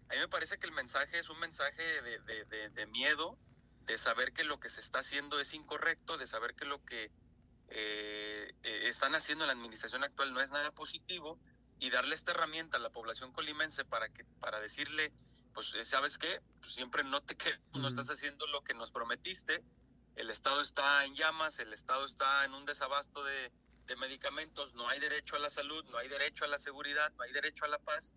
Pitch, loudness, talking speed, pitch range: 145 Hz, -37 LUFS, 215 wpm, 135-155 Hz